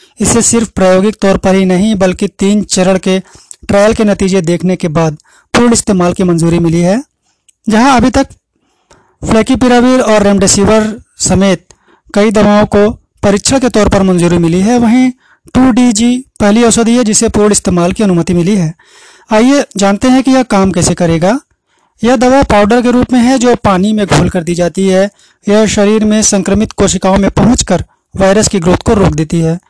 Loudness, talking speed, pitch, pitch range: -9 LUFS, 180 wpm, 205 Hz, 190-230 Hz